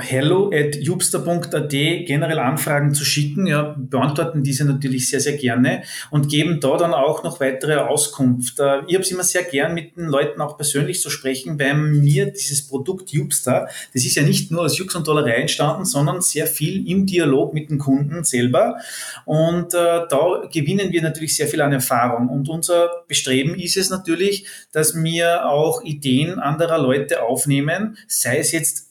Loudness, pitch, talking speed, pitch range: -19 LUFS, 150 Hz, 180 wpm, 140-170 Hz